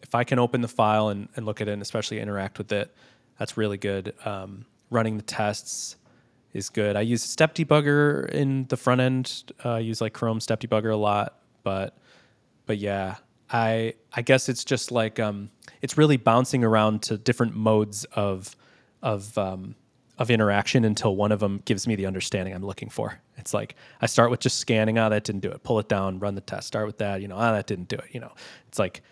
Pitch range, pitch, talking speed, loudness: 105-120 Hz, 110 Hz, 220 wpm, -25 LUFS